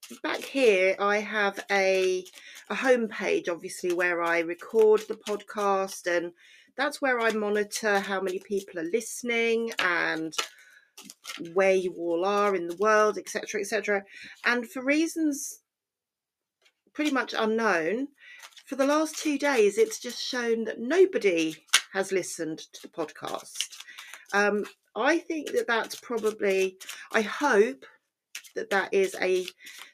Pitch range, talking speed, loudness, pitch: 190-270 Hz, 135 wpm, -27 LUFS, 210 Hz